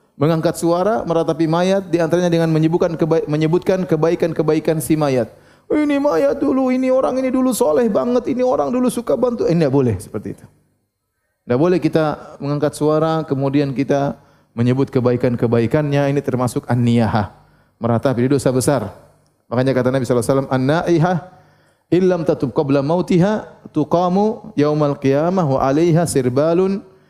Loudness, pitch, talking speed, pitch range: -17 LUFS, 155 Hz, 135 wpm, 135-180 Hz